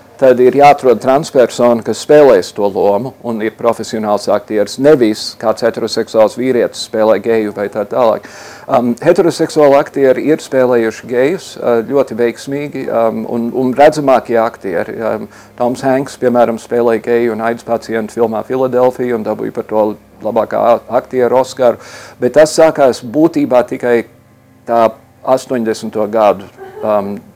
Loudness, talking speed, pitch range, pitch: -12 LUFS, 130 wpm, 110-130 Hz, 120 Hz